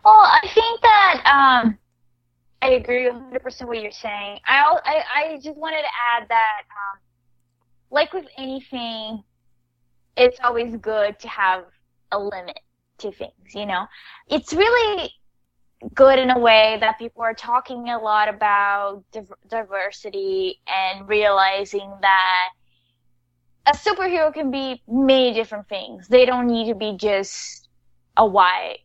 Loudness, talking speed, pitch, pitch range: -19 LUFS, 140 wpm, 225 Hz, 195-265 Hz